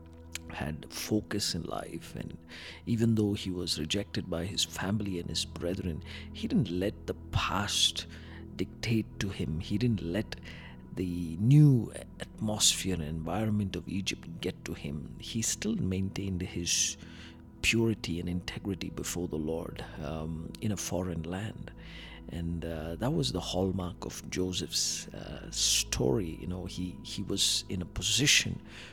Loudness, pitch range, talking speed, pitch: -31 LUFS, 80-105 Hz, 145 wpm, 90 Hz